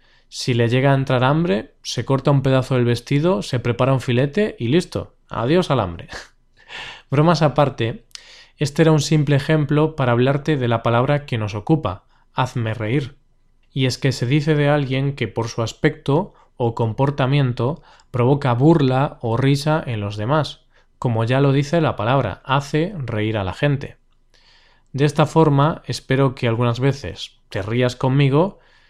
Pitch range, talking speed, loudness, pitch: 120-150 Hz, 165 wpm, -19 LUFS, 135 Hz